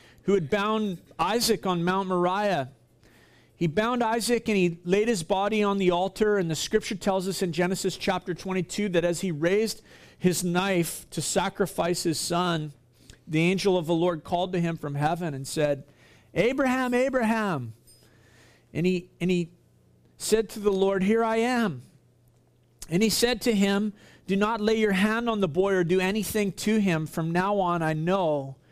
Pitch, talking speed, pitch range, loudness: 185 Hz, 180 wpm, 165-210 Hz, -26 LUFS